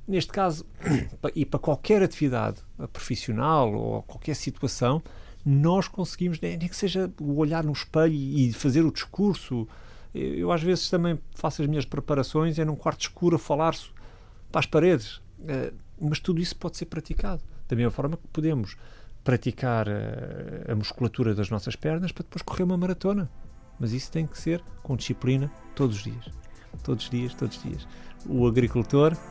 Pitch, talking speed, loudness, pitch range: 145 Hz, 165 wpm, -27 LUFS, 120-165 Hz